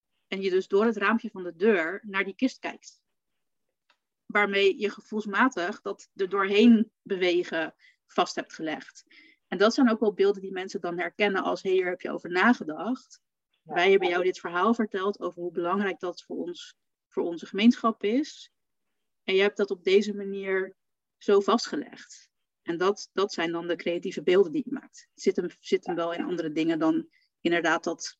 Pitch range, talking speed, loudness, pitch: 185-245 Hz, 185 wpm, -27 LUFS, 200 Hz